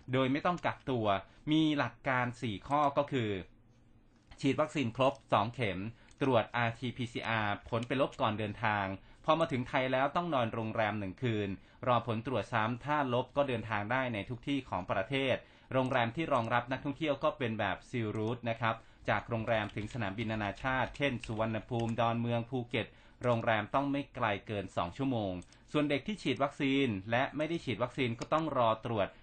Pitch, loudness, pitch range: 120 Hz, -34 LUFS, 110-135 Hz